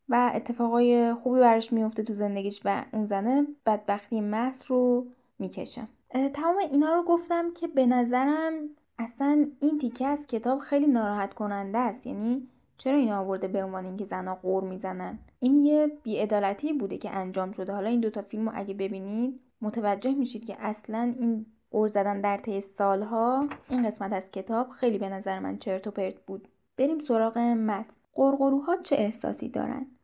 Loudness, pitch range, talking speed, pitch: -28 LUFS, 200-265 Hz, 165 wpm, 230 Hz